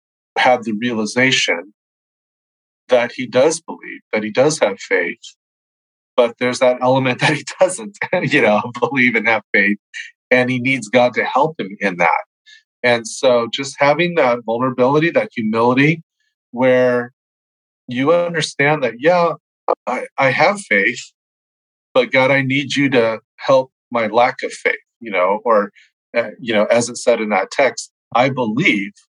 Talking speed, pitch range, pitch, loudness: 155 wpm, 120-155 Hz, 130 Hz, -16 LUFS